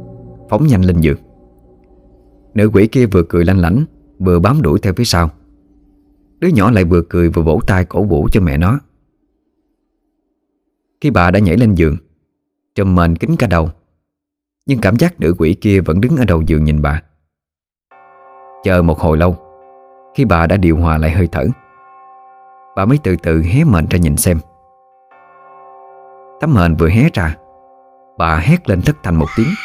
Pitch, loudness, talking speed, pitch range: 90 Hz, -13 LUFS, 175 wpm, 80-125 Hz